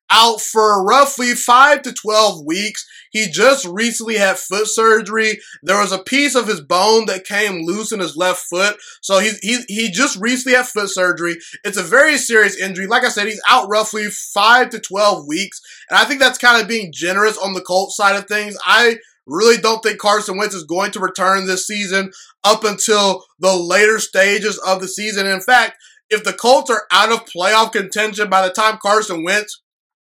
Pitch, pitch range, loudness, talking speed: 210 Hz, 195-225 Hz, -14 LUFS, 200 wpm